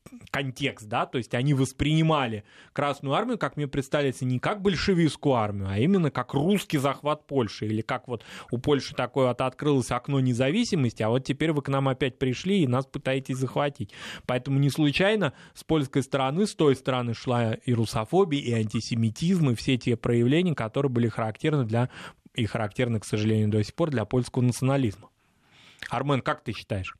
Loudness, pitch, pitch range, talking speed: -26 LUFS, 130 Hz, 120-145 Hz, 175 wpm